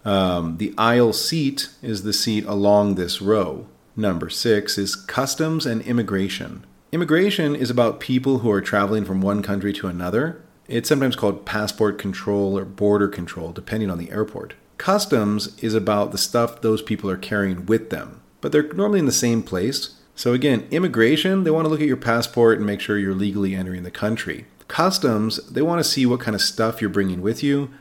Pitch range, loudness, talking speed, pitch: 100-125 Hz, -21 LUFS, 190 wpm, 110 Hz